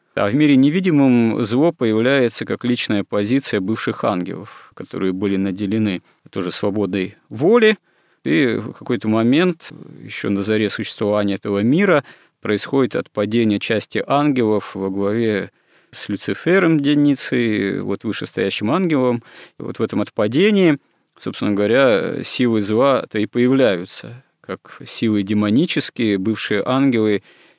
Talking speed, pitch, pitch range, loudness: 120 wpm, 110 Hz, 100-135 Hz, -18 LUFS